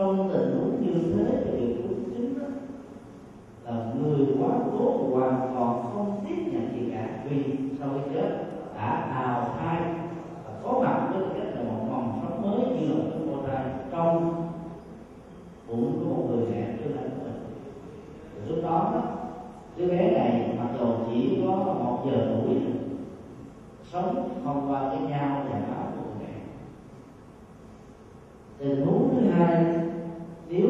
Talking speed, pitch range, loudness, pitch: 145 wpm, 120-175 Hz, -28 LUFS, 140 Hz